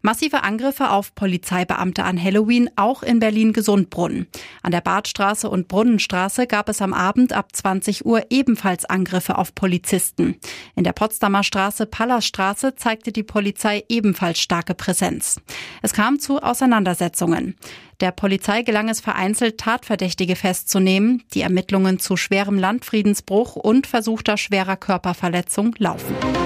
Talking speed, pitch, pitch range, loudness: 130 wpm, 200 Hz, 190-225 Hz, -19 LUFS